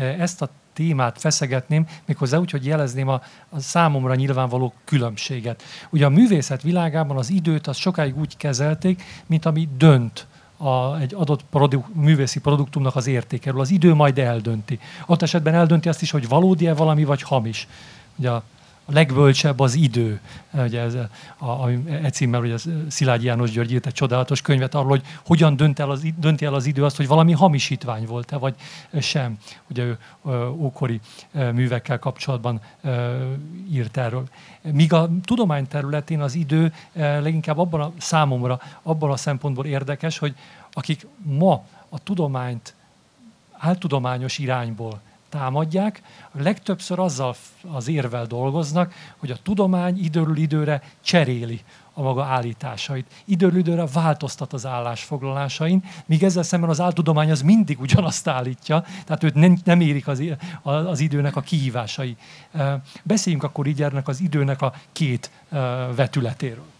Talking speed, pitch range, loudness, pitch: 140 wpm, 130-160 Hz, -21 LUFS, 145 Hz